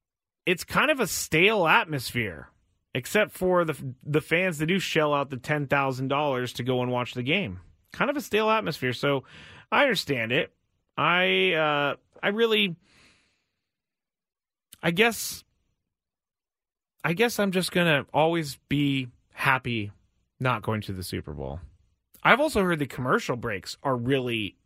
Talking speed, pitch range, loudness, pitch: 150 wpm, 120-175 Hz, -25 LUFS, 140 Hz